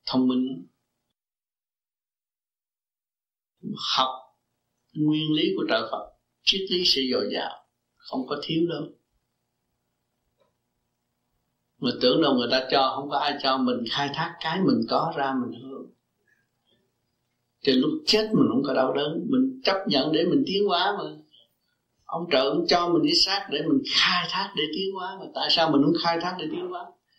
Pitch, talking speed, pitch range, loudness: 160 Hz, 170 wpm, 130-195 Hz, -24 LUFS